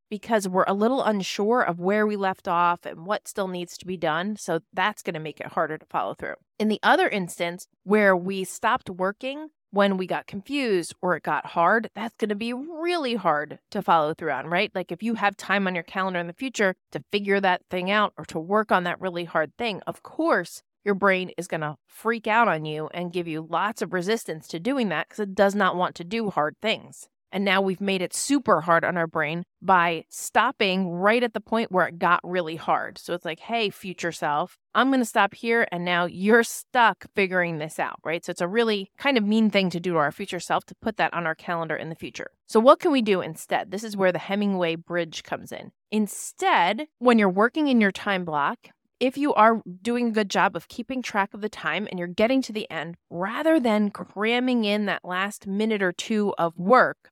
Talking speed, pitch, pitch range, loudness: 235 wpm, 195 Hz, 175-220 Hz, -24 LUFS